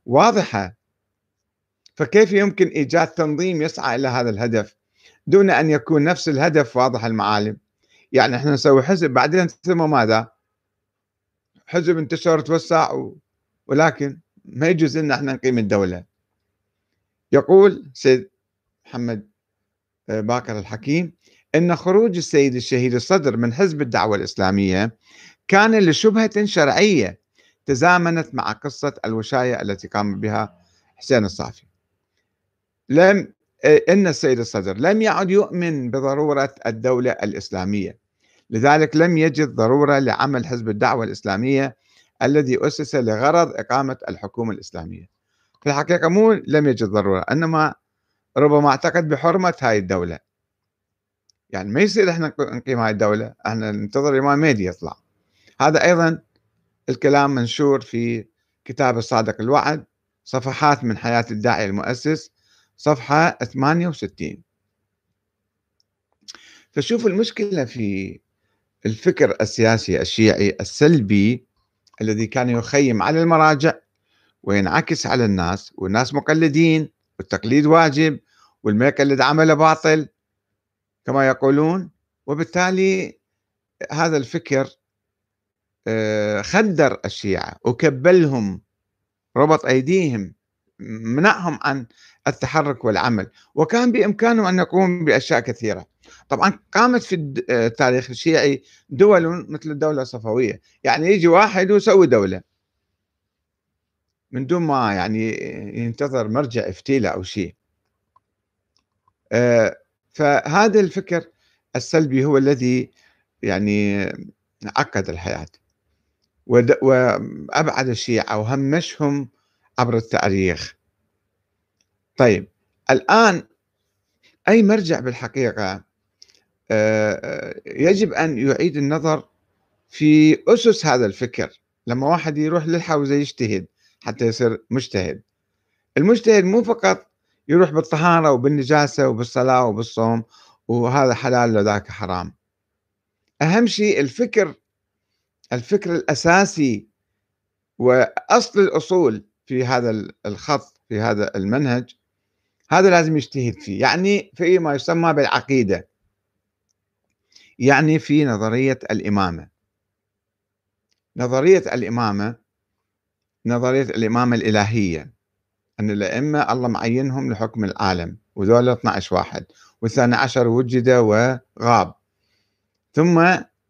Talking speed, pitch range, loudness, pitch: 95 wpm, 105-155 Hz, -18 LUFS, 125 Hz